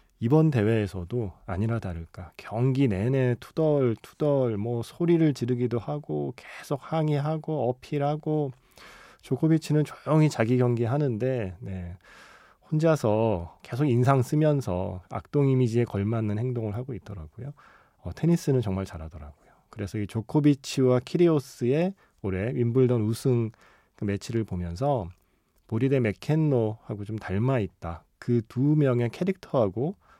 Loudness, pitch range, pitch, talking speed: -26 LUFS, 105-145 Hz, 120 Hz, 295 characters per minute